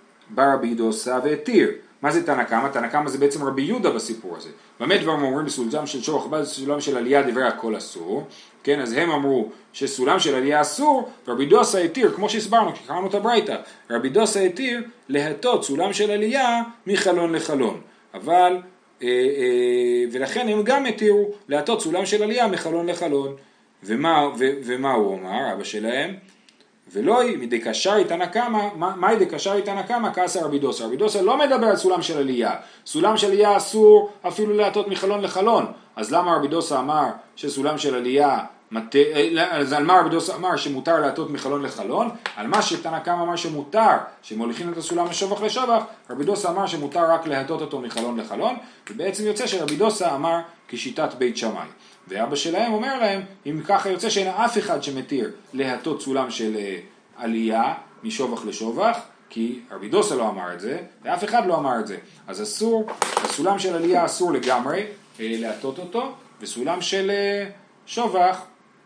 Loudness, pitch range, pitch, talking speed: -22 LUFS, 145-210 Hz, 180 Hz, 165 wpm